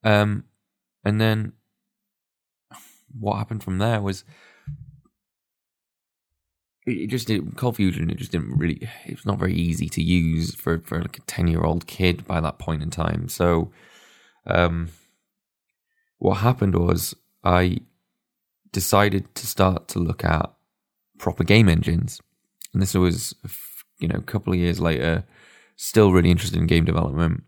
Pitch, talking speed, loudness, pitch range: 95 Hz, 150 wpm, -23 LUFS, 85-110 Hz